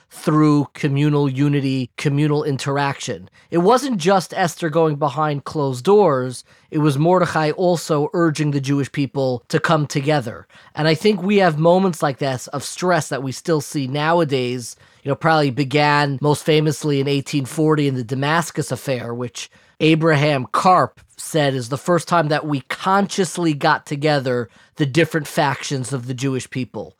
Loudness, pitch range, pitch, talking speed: -19 LUFS, 140-165 Hz, 150 Hz, 160 wpm